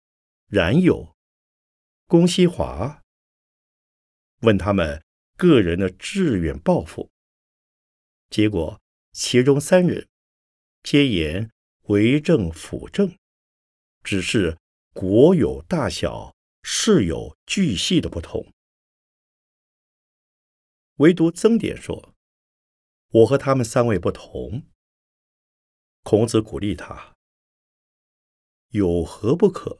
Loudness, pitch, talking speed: -20 LUFS, 105 Hz, 125 characters per minute